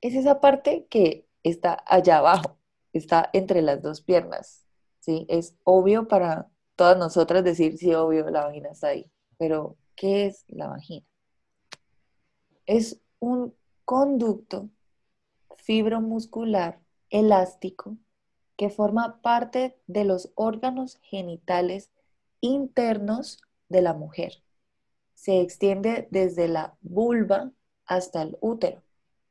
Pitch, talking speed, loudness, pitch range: 195 Hz, 110 wpm, -24 LUFS, 170-225 Hz